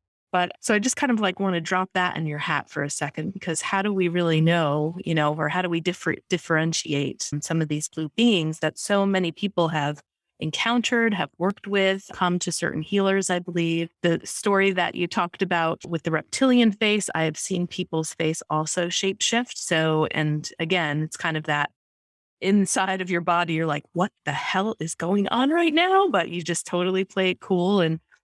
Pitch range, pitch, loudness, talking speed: 160-195 Hz, 175 Hz, -24 LUFS, 210 wpm